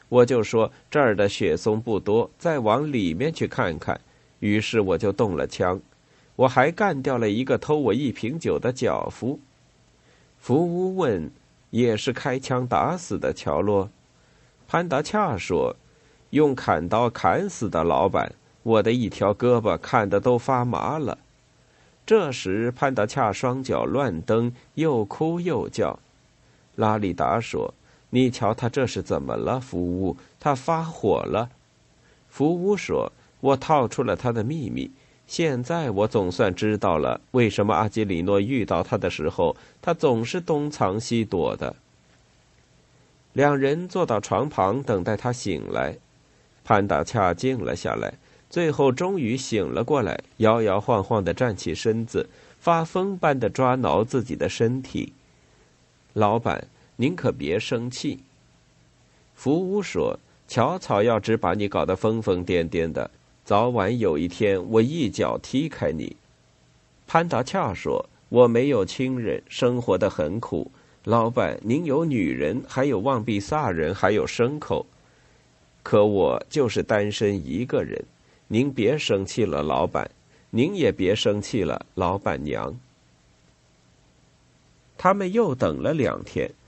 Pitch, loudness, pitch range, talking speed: 120 Hz, -24 LUFS, 105-140 Hz, 200 characters per minute